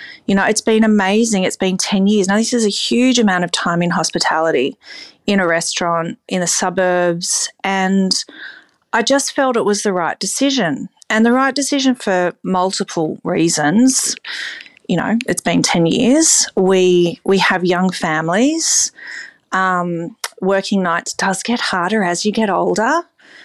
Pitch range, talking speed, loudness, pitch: 180-235 Hz, 160 wpm, -15 LUFS, 195 Hz